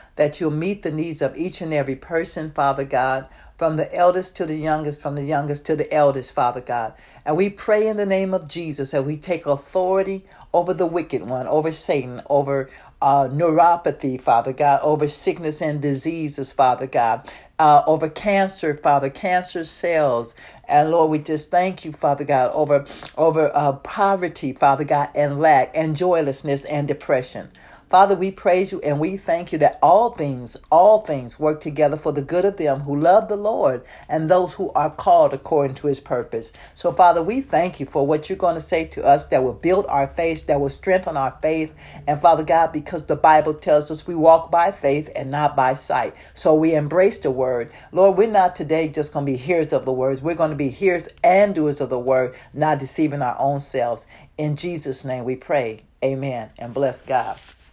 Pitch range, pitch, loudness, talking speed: 140-175 Hz, 155 Hz, -20 LUFS, 200 wpm